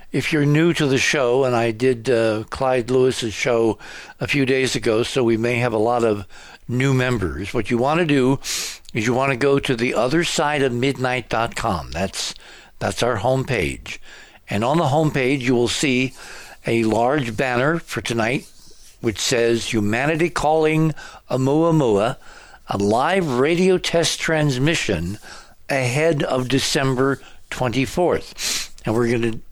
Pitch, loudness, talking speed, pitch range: 130 Hz, -20 LUFS, 155 wpm, 115-140 Hz